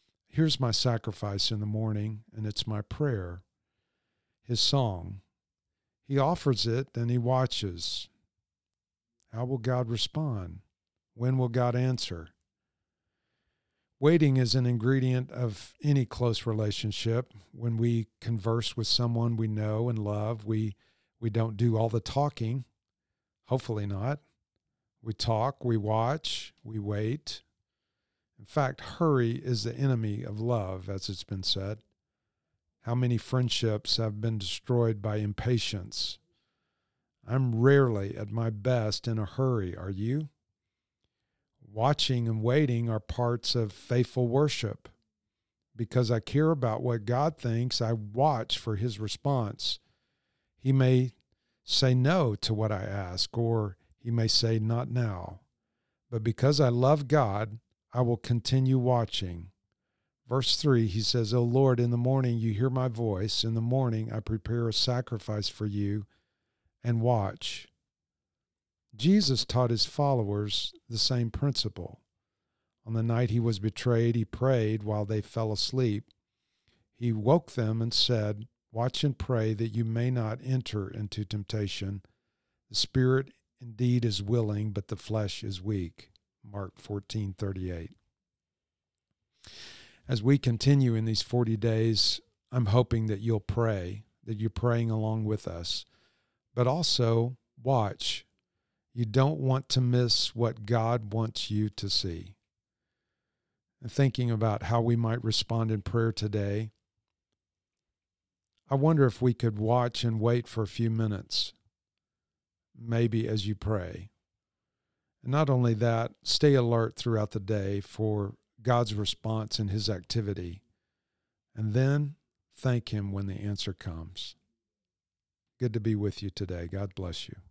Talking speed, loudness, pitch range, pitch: 135 wpm, -29 LUFS, 105-125 Hz, 115 Hz